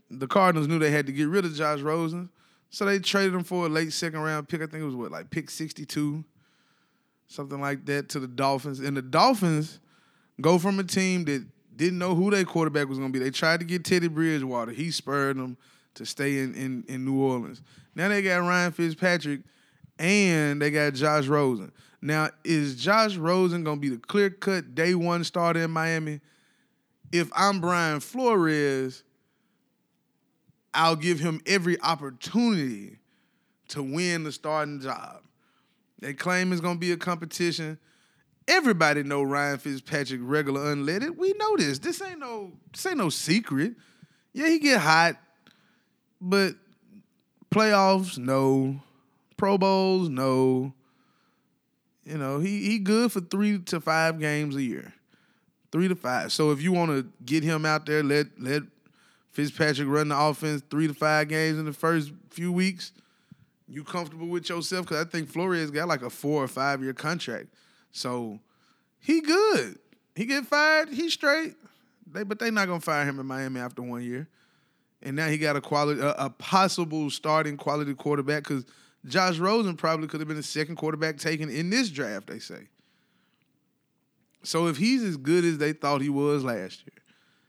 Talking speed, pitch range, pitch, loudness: 175 wpm, 145-185 Hz, 160 Hz, -26 LUFS